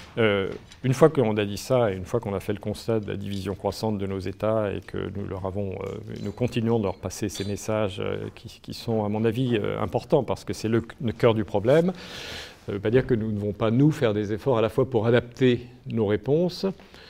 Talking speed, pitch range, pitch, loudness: 255 wpm, 100-120 Hz, 110 Hz, -26 LUFS